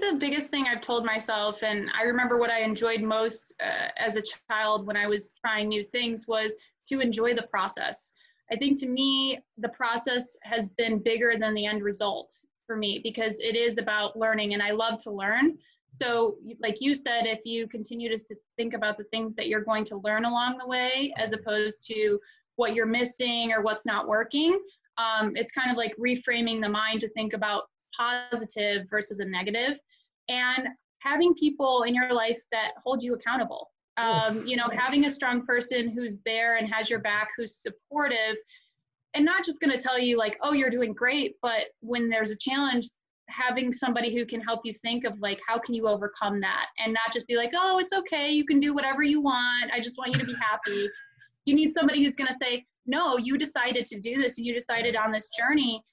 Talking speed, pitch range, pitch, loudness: 210 wpm, 220-260 Hz, 235 Hz, -27 LUFS